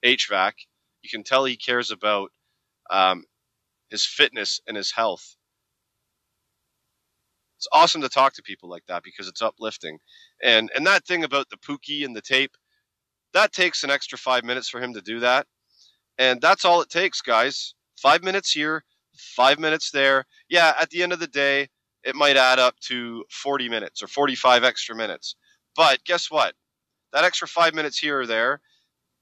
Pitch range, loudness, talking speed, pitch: 115-160 Hz, -21 LUFS, 175 wpm, 135 Hz